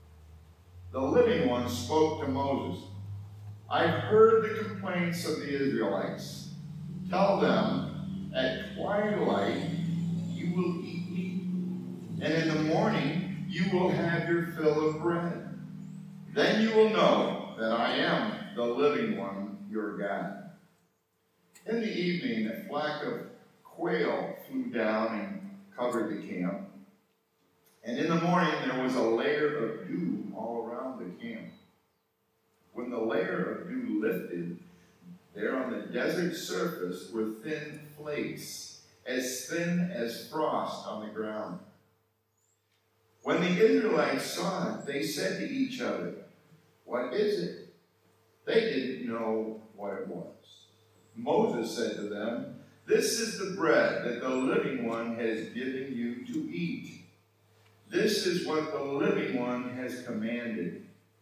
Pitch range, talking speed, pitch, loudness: 115-180 Hz, 130 wpm, 155 Hz, -31 LUFS